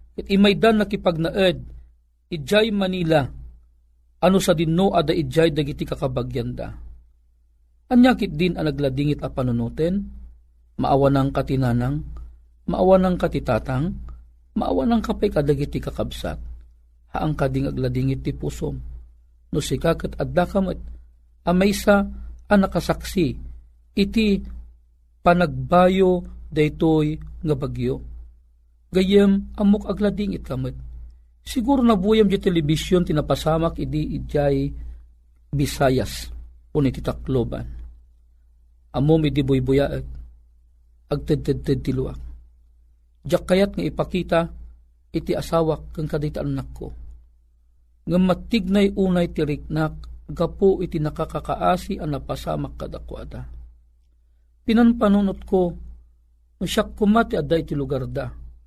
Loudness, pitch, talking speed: -22 LUFS, 140 Hz, 95 wpm